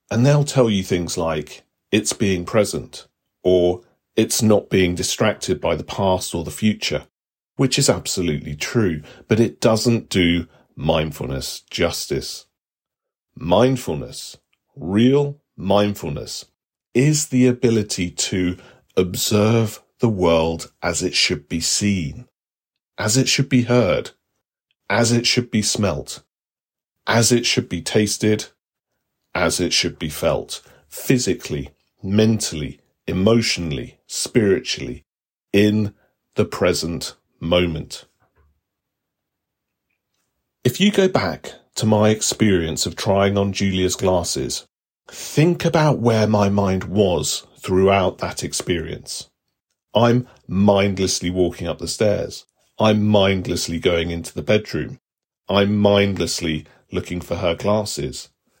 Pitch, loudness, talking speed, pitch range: 100 Hz, -19 LUFS, 115 wpm, 90-115 Hz